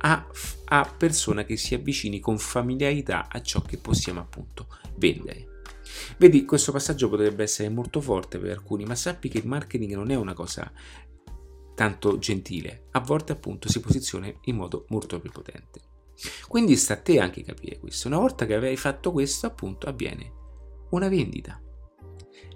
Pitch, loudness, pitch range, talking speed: 105 Hz, -25 LUFS, 85-140 Hz, 160 wpm